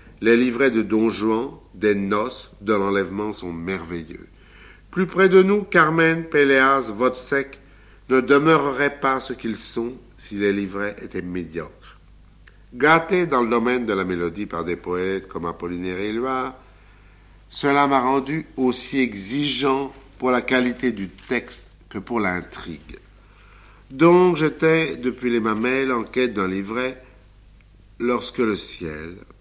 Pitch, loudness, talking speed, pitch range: 120 Hz, -21 LUFS, 140 wpm, 100-135 Hz